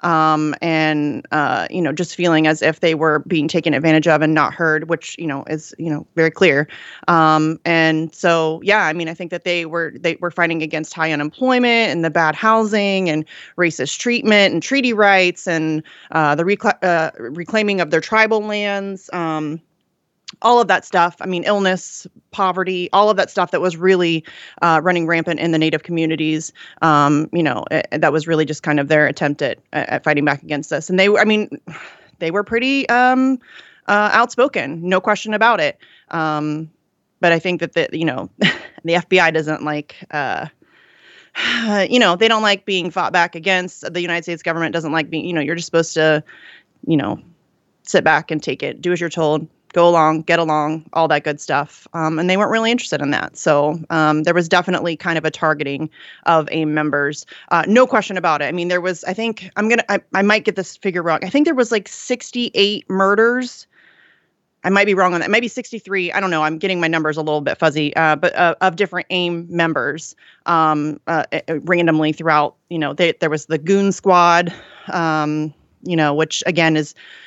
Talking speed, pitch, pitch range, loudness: 205 wpm, 170 Hz, 155-195 Hz, -17 LUFS